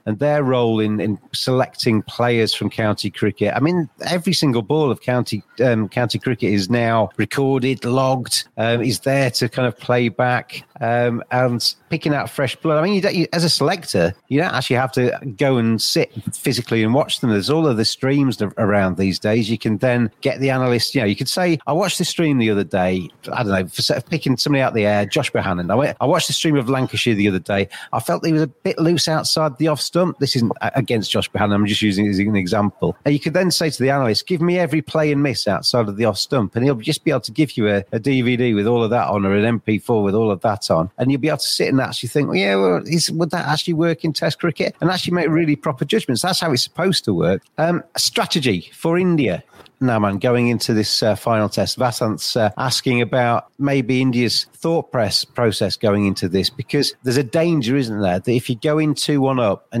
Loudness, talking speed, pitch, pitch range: -18 LUFS, 245 wpm, 125 Hz, 110-150 Hz